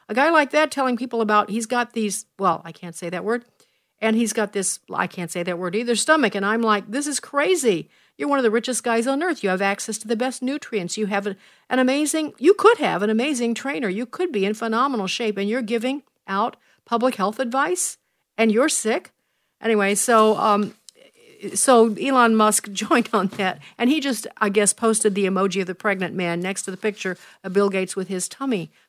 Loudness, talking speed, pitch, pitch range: -21 LUFS, 220 wpm, 225 Hz, 195-255 Hz